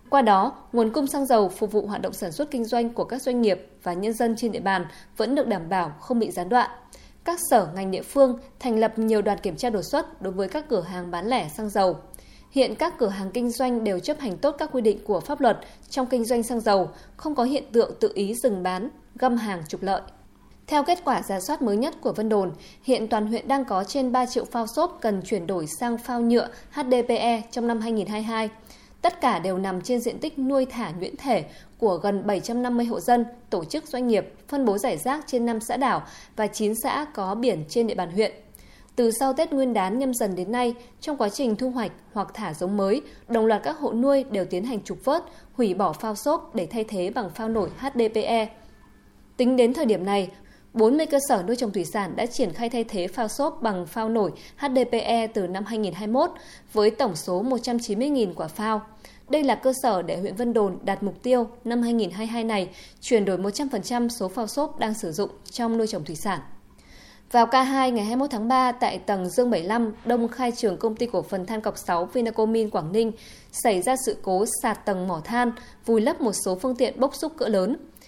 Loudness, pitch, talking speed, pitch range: -25 LUFS, 230 Hz, 225 wpm, 200-255 Hz